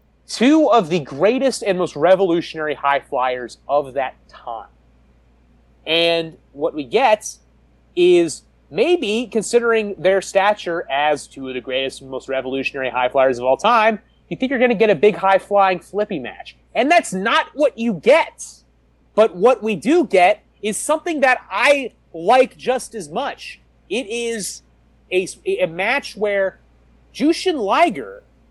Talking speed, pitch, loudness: 155 wpm, 190 Hz, -18 LUFS